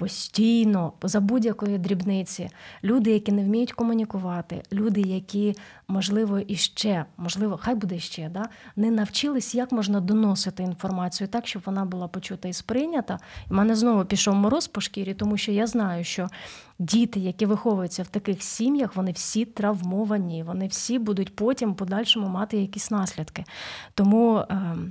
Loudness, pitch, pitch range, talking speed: -25 LUFS, 205 Hz, 185-220 Hz, 145 wpm